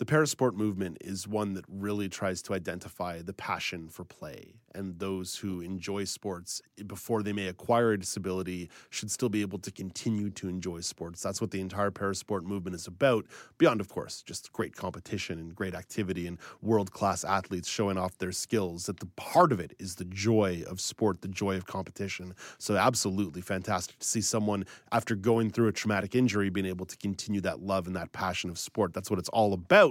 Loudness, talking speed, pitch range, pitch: -31 LUFS, 205 wpm, 95-105 Hz, 100 Hz